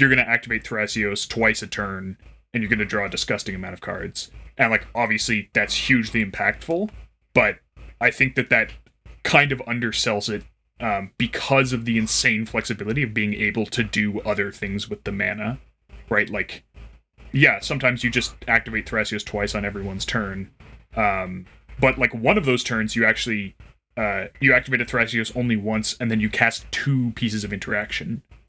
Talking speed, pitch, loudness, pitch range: 180 wpm, 110 Hz, -22 LUFS, 105-120 Hz